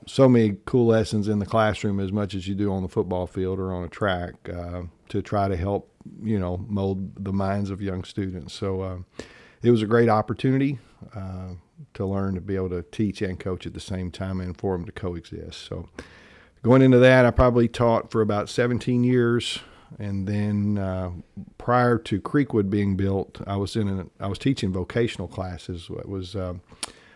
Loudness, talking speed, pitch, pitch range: -24 LUFS, 200 wpm, 100 Hz, 95-110 Hz